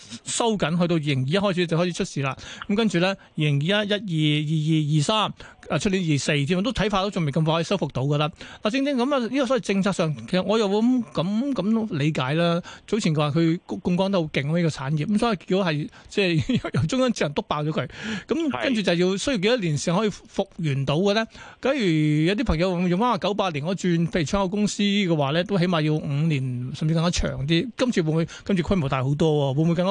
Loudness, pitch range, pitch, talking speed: -23 LUFS, 155-205 Hz, 180 Hz, 355 characters per minute